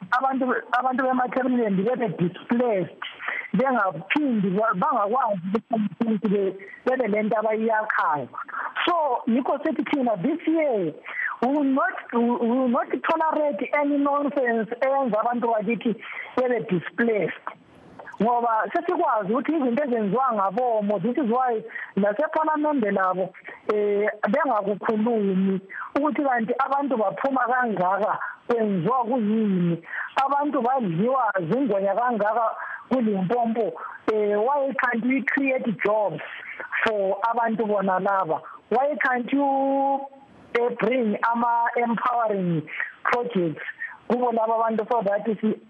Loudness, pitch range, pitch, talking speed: -24 LUFS, 215-270 Hz, 235 Hz, 90 wpm